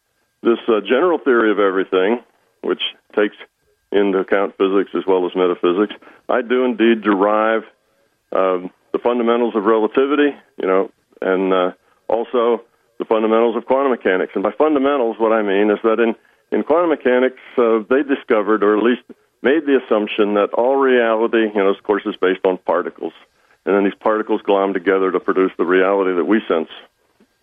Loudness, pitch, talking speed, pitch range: -17 LUFS, 110 Hz, 175 wpm, 95-120 Hz